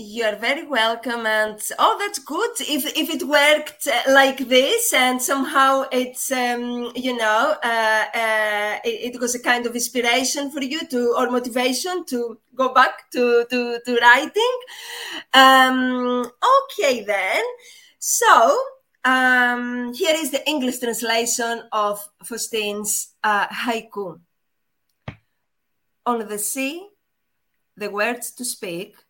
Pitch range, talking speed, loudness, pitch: 230-275 Hz, 130 wpm, -19 LUFS, 245 Hz